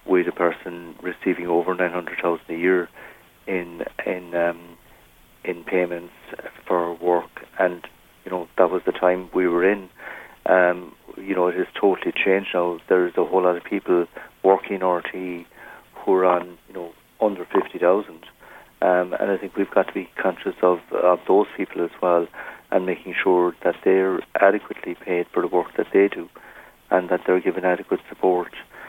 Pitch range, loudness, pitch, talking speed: 85-90 Hz, -22 LUFS, 90 Hz, 170 wpm